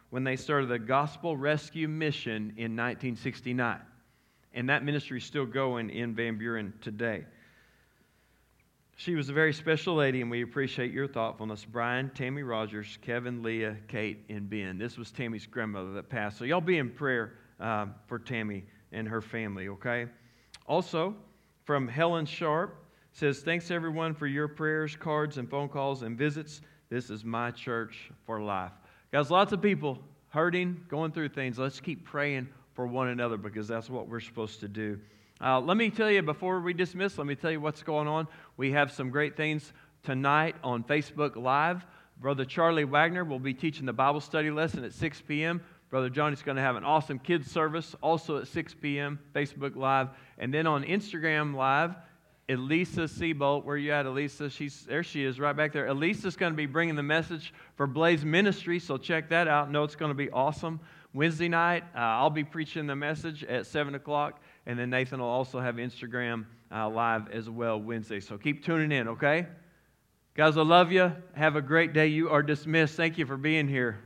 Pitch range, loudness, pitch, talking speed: 120-160 Hz, -30 LUFS, 145 Hz, 190 wpm